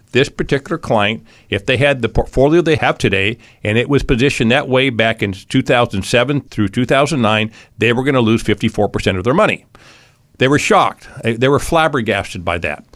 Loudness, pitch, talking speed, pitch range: -15 LUFS, 120 Hz, 180 wpm, 110-135 Hz